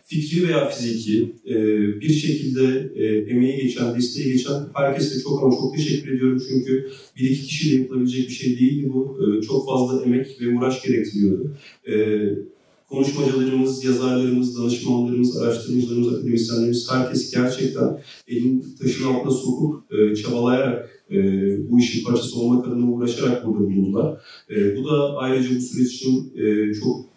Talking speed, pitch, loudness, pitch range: 125 wpm, 125 Hz, -21 LUFS, 120-130 Hz